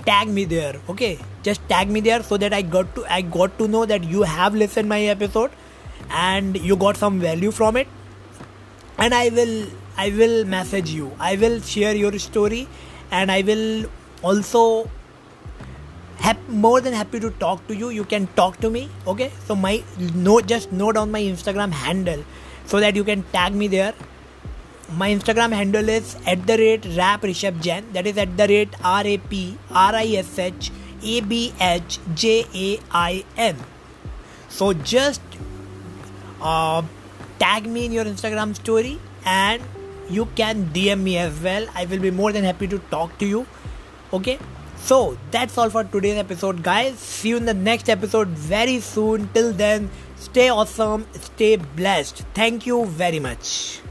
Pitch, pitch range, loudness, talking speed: 205 Hz, 180-225 Hz, -20 LUFS, 175 wpm